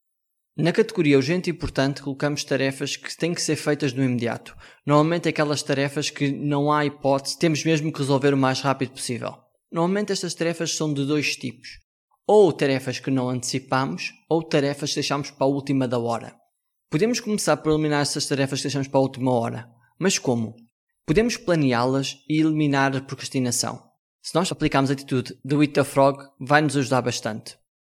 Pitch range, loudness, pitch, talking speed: 135-155 Hz, -23 LUFS, 140 Hz, 175 wpm